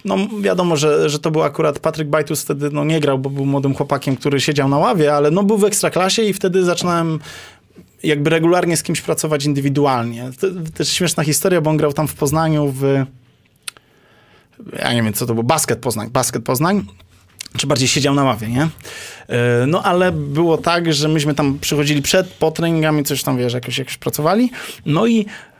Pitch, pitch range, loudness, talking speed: 150 Hz, 135-165 Hz, -17 LUFS, 190 wpm